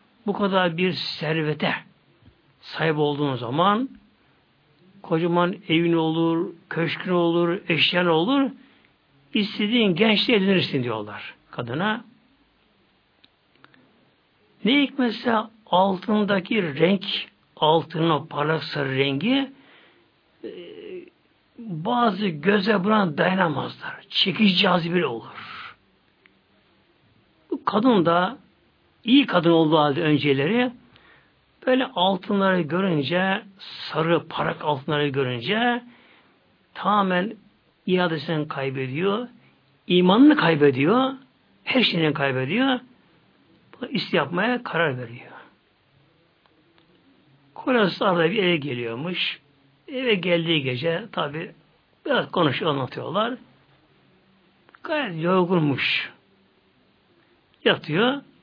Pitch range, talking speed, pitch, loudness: 160-225 Hz, 80 wpm, 180 Hz, -22 LUFS